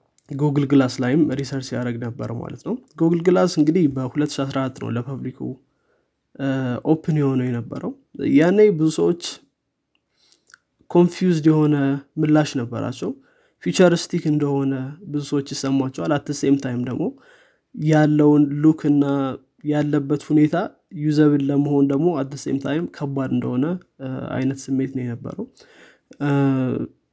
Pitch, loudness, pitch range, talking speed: 145 Hz, -21 LUFS, 135-155 Hz, 110 wpm